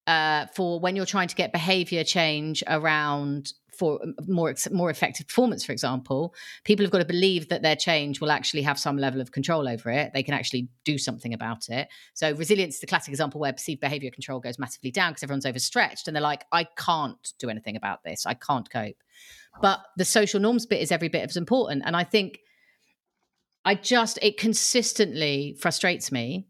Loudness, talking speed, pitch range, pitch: -25 LUFS, 200 wpm, 140-185 Hz, 155 Hz